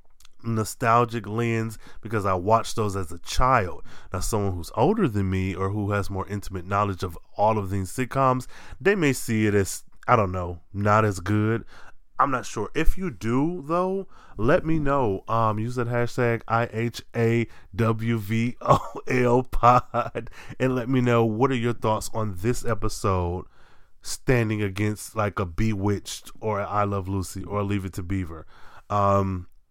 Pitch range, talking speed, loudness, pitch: 100-120 Hz, 175 wpm, -25 LUFS, 110 Hz